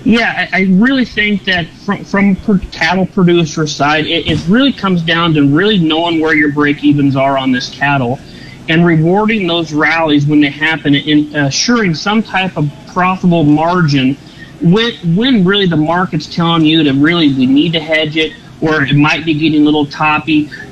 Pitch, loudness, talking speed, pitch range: 160 Hz, -11 LUFS, 185 wpm, 150-185 Hz